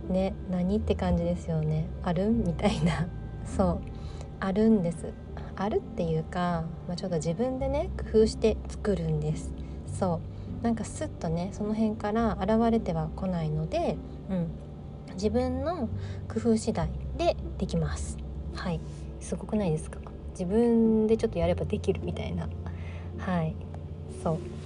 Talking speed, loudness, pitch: 285 characters per minute, -30 LUFS, 160 Hz